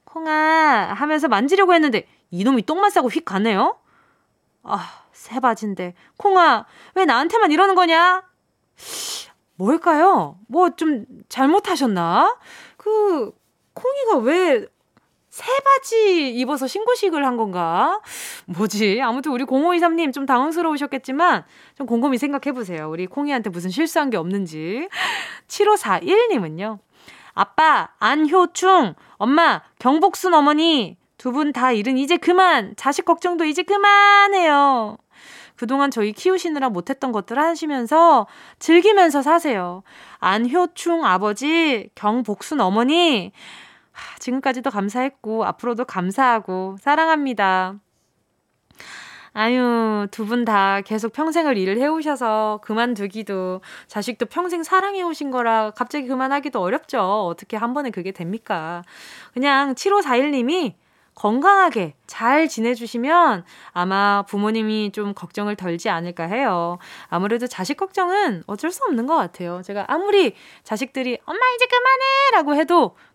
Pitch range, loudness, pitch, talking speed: 215-335 Hz, -19 LUFS, 270 Hz, 275 characters per minute